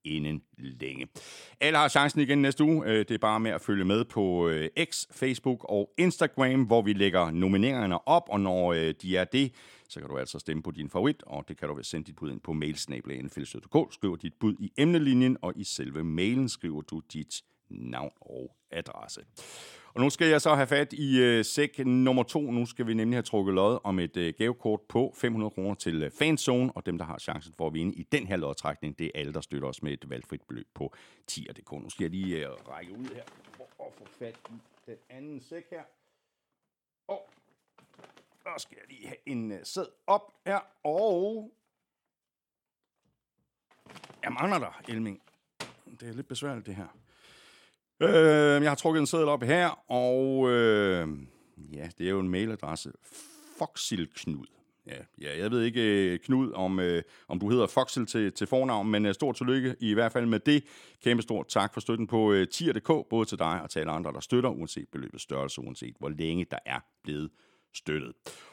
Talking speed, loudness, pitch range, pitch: 195 wpm, -29 LUFS, 80-130 Hz, 110 Hz